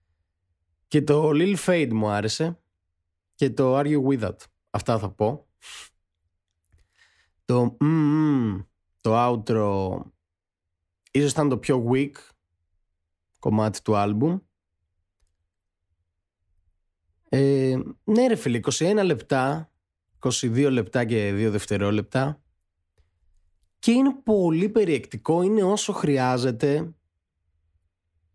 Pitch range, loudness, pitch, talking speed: 85-140 Hz, -23 LUFS, 110 Hz, 95 wpm